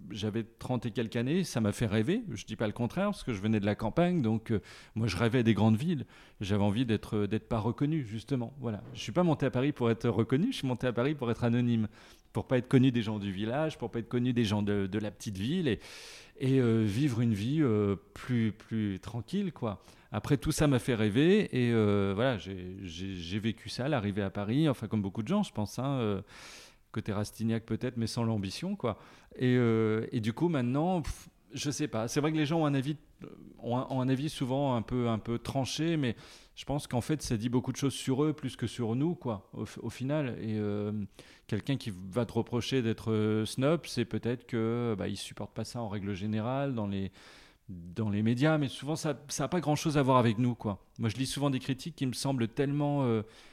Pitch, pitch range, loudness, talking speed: 120 Hz, 110-135 Hz, -32 LUFS, 245 wpm